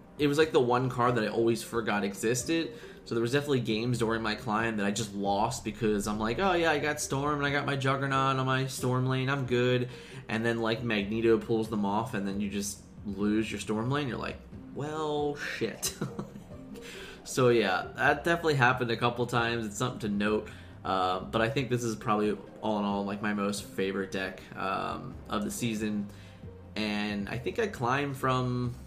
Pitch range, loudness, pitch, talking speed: 105-130 Hz, -30 LUFS, 115 Hz, 205 wpm